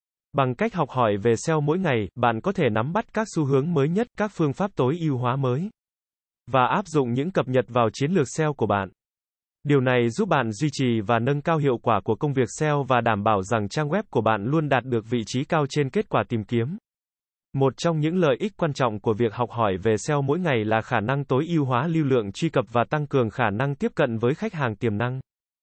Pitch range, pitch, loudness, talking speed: 120-155 Hz, 135 Hz, -24 LUFS, 255 wpm